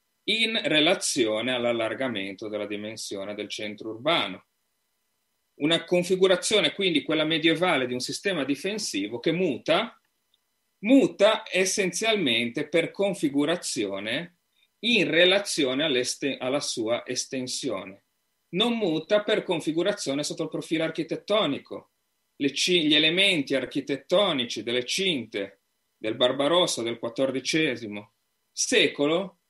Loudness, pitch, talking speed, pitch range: -25 LUFS, 160 Hz, 100 wpm, 125-190 Hz